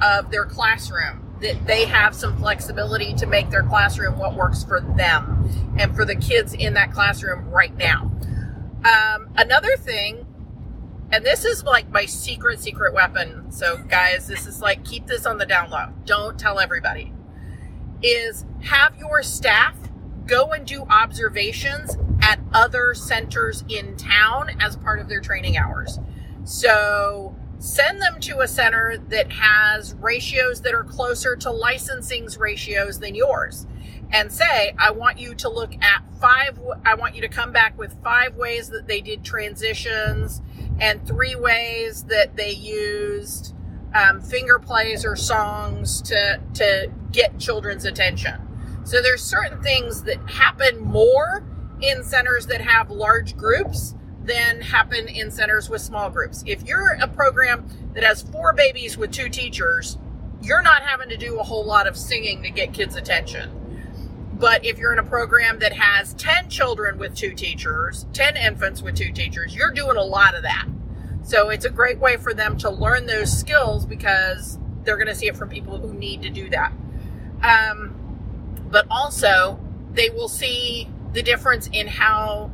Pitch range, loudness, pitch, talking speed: 200-305 Hz, -19 LUFS, 240 Hz, 165 wpm